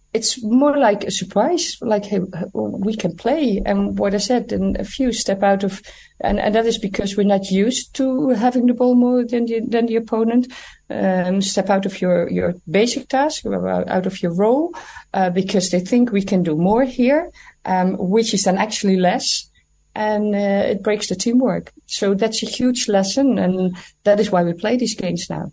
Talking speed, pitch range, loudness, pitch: 200 wpm, 190-245 Hz, -18 LUFS, 210 Hz